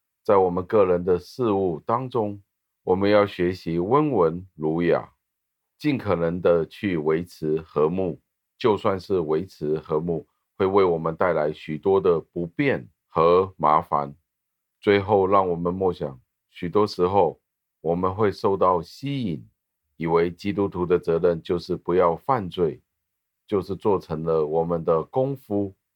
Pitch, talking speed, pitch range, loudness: 85 Hz, 210 characters per minute, 80-100 Hz, -23 LUFS